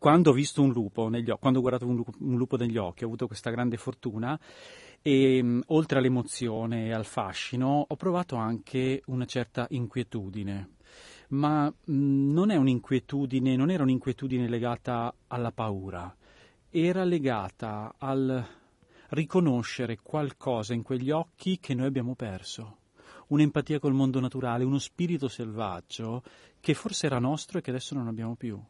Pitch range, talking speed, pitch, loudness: 115-140 Hz, 155 wpm, 130 Hz, -29 LUFS